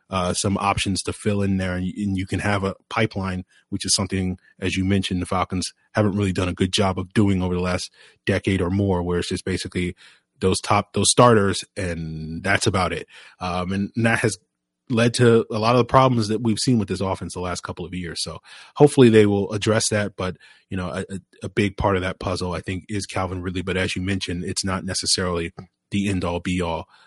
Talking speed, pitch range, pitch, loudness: 230 wpm, 90-105 Hz, 95 Hz, -22 LUFS